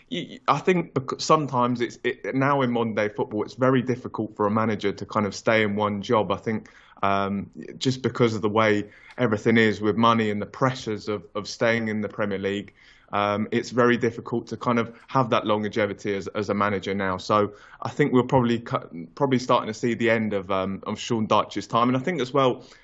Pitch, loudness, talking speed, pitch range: 110 Hz, -24 LUFS, 220 wpm, 105-125 Hz